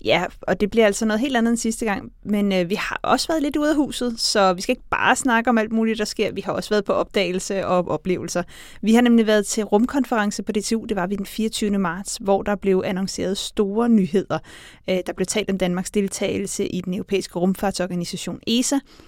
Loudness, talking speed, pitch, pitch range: -21 LUFS, 225 wpm, 205 Hz, 190-225 Hz